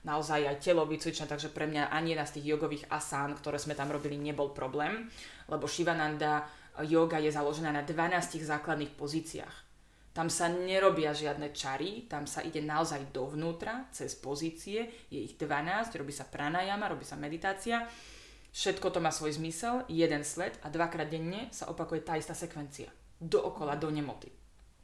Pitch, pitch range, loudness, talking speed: 155 Hz, 145-170 Hz, -34 LUFS, 160 wpm